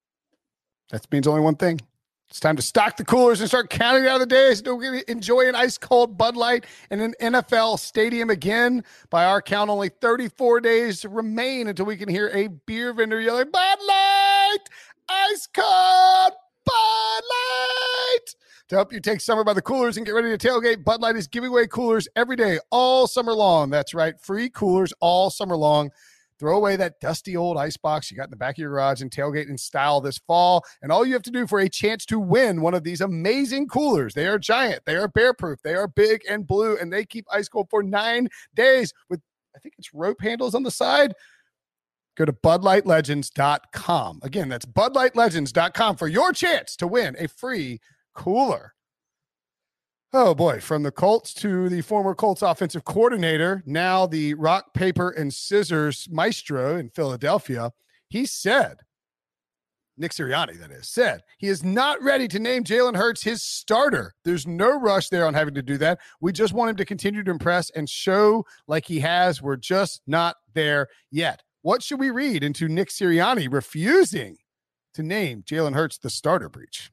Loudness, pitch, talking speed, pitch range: -21 LUFS, 205 Hz, 185 wpm, 160-240 Hz